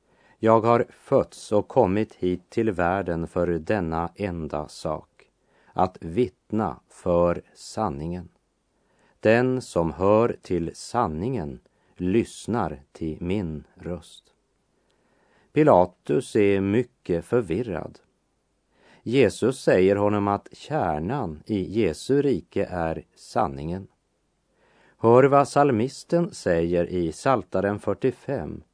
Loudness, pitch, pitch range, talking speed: -24 LUFS, 95 Hz, 85-115 Hz, 95 wpm